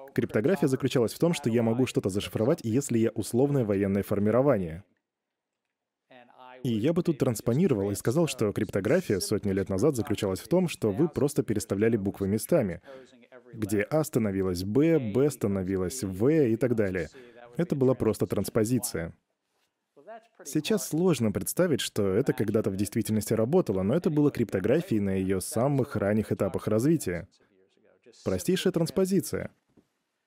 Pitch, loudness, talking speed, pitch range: 115 Hz, -27 LUFS, 140 wpm, 105-140 Hz